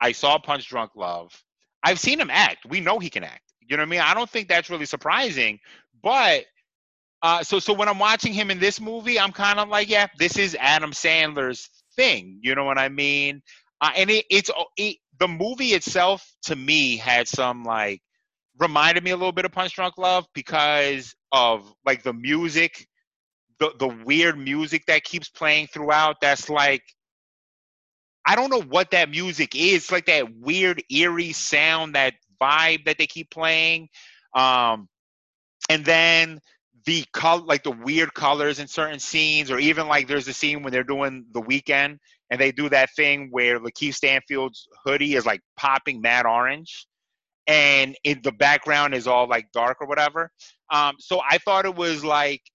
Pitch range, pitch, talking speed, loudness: 135-175 Hz, 150 Hz, 185 wpm, -21 LUFS